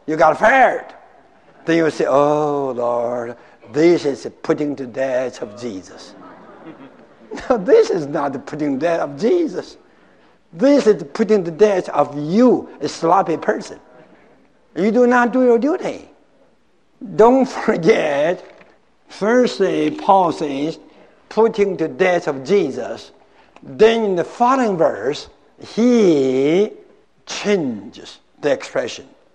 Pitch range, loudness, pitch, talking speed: 150-245 Hz, -17 LUFS, 195 Hz, 120 wpm